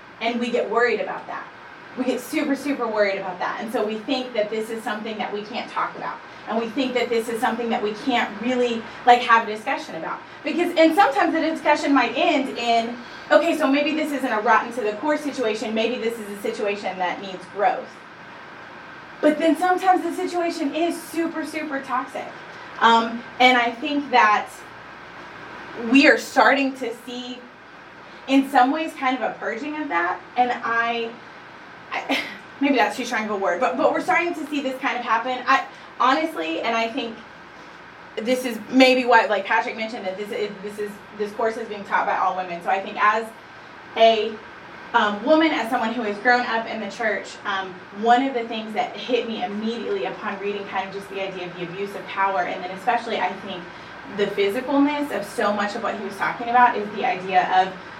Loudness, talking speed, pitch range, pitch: -22 LUFS, 205 wpm, 210-275 Hz, 235 Hz